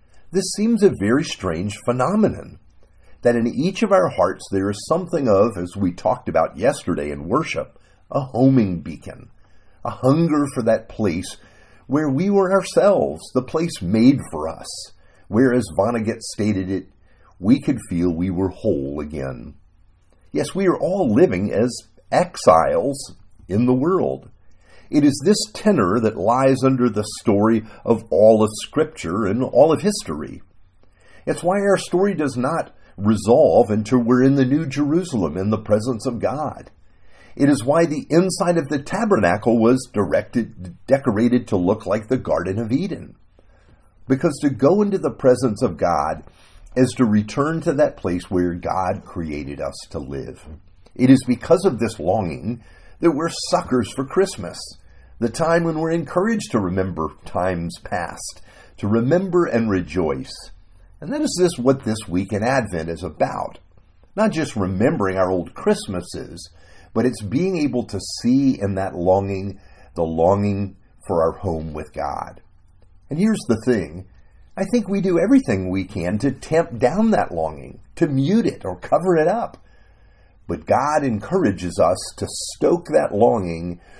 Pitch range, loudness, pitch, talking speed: 95-140 Hz, -20 LUFS, 110 Hz, 160 wpm